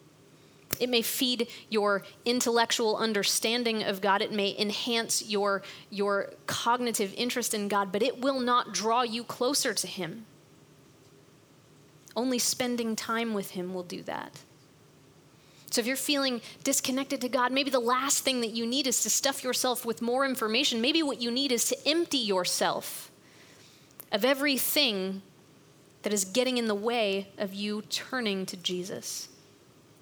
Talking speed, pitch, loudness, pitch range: 150 wpm, 230 Hz, -28 LUFS, 200-250 Hz